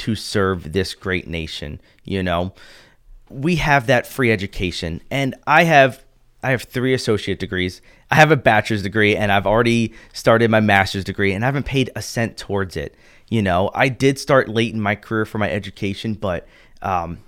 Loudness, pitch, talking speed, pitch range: -19 LUFS, 110 Hz, 190 wpm, 100-130 Hz